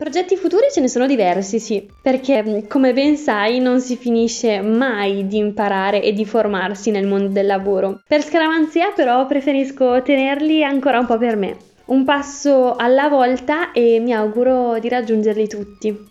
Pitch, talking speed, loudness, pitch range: 245 Hz, 165 wpm, -17 LUFS, 215-275 Hz